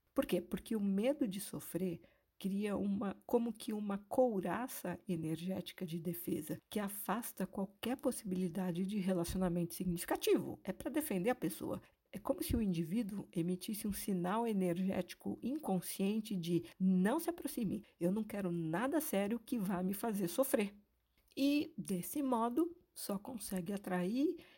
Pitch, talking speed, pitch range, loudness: 200 Hz, 140 wpm, 185-245 Hz, -38 LUFS